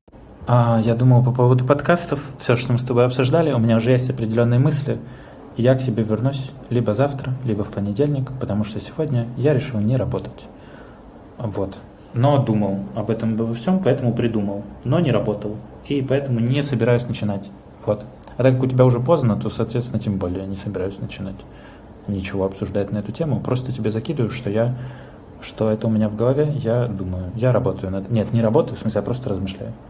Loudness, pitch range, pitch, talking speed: -21 LUFS, 105-130 Hz, 120 Hz, 190 wpm